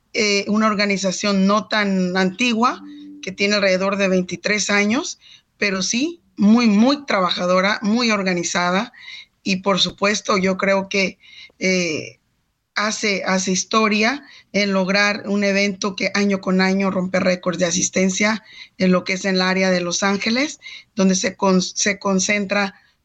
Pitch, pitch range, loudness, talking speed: 200 Hz, 190-215 Hz, -18 LUFS, 145 wpm